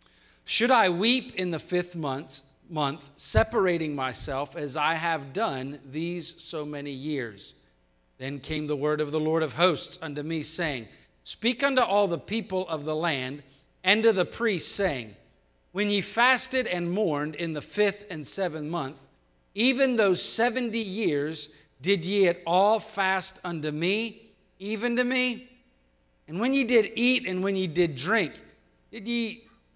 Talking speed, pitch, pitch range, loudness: 160 wpm, 175 Hz, 150-215 Hz, -26 LUFS